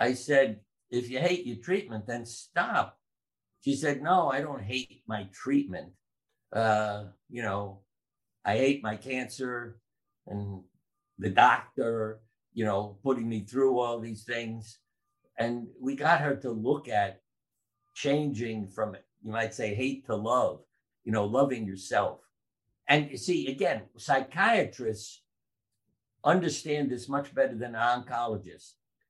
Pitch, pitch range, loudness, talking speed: 120 Hz, 110-135 Hz, -30 LUFS, 135 wpm